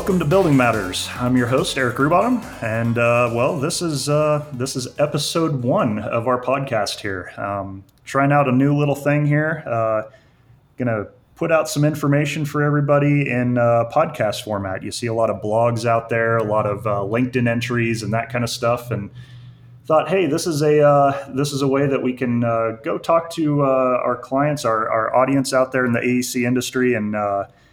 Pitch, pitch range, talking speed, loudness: 125 Hz, 115-145 Hz, 205 wpm, -19 LUFS